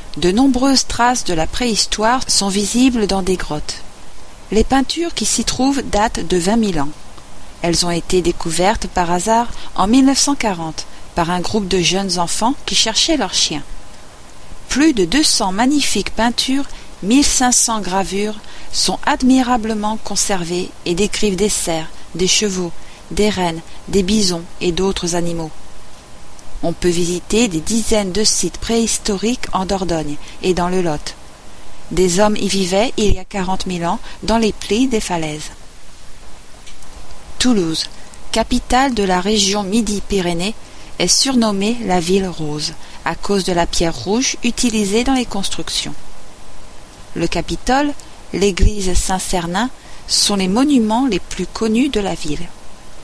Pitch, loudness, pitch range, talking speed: 200 Hz, -16 LUFS, 175-230 Hz, 145 wpm